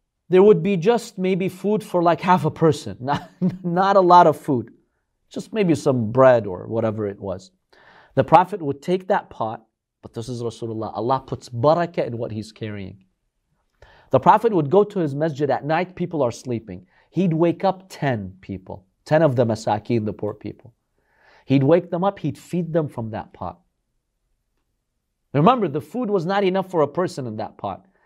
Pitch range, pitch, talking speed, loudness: 115-180 Hz, 150 Hz, 190 wpm, -20 LUFS